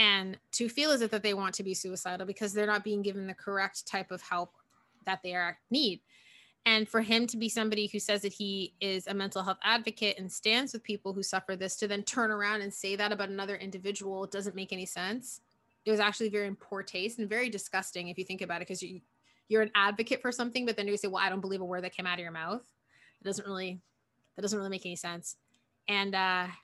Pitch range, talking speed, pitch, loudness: 190-215 Hz, 250 wpm, 200 Hz, -32 LUFS